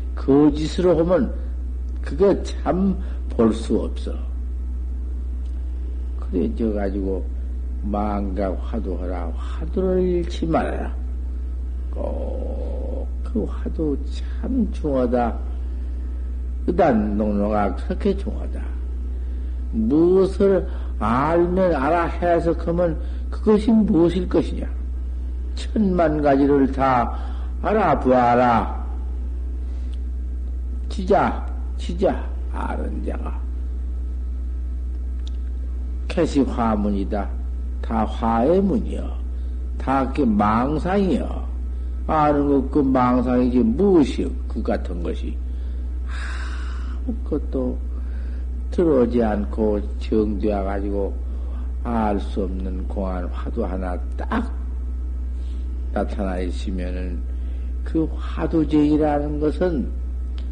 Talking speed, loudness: 170 characters per minute, -23 LUFS